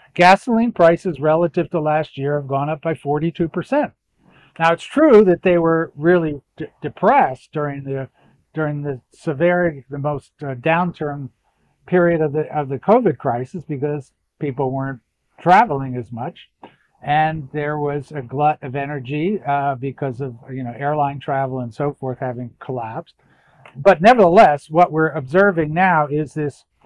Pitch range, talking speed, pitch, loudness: 140-170 Hz, 155 wpm, 150 Hz, -18 LUFS